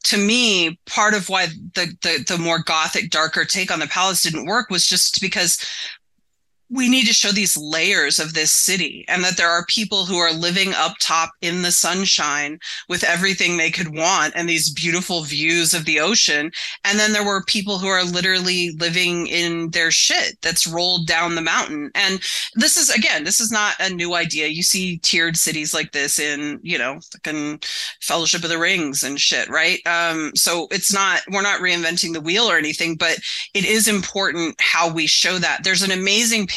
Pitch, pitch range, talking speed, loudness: 175 Hz, 165-195 Hz, 195 wpm, -17 LUFS